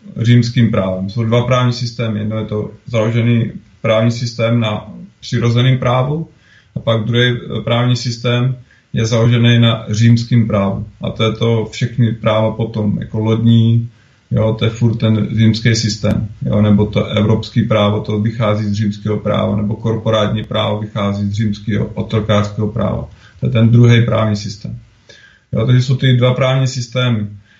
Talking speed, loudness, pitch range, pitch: 155 wpm, -15 LUFS, 105-120 Hz, 110 Hz